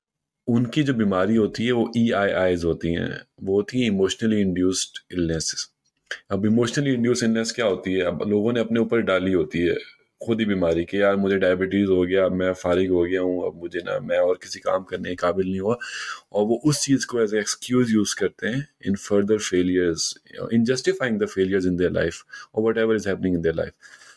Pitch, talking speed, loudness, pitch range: 100 Hz, 210 wpm, -23 LUFS, 90-115 Hz